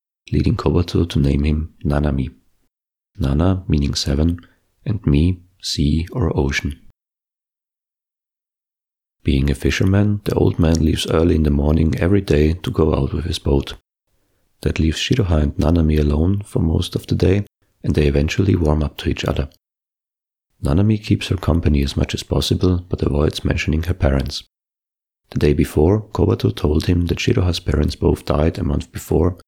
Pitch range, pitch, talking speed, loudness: 75-95 Hz, 80 Hz, 160 wpm, -19 LUFS